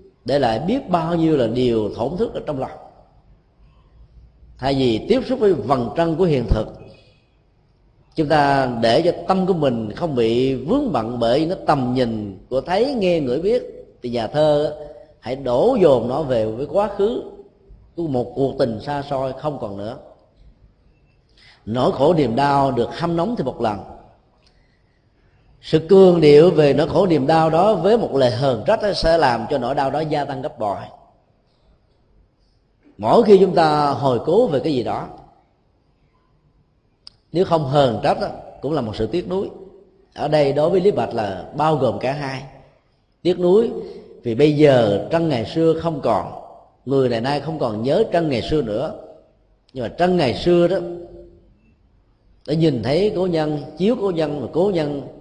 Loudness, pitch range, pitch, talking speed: -19 LUFS, 125-175 Hz, 150 Hz, 180 wpm